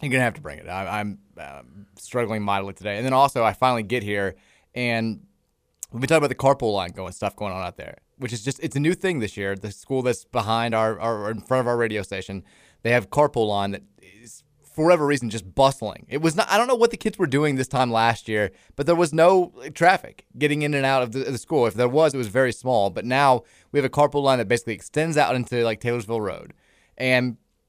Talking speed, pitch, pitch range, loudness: 255 wpm, 120 Hz, 105-140 Hz, -23 LUFS